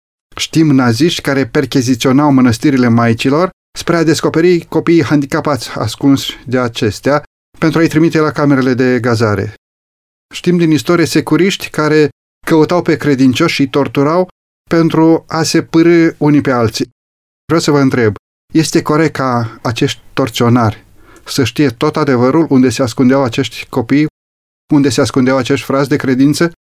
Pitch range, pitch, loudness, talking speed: 125-160 Hz, 140 Hz, -12 LUFS, 140 wpm